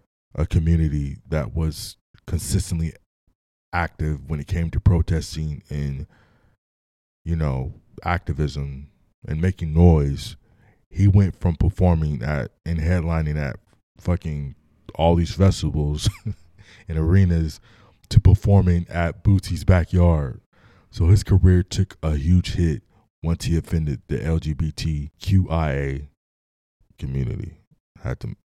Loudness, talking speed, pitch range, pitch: -22 LUFS, 110 wpm, 75-95 Hz, 85 Hz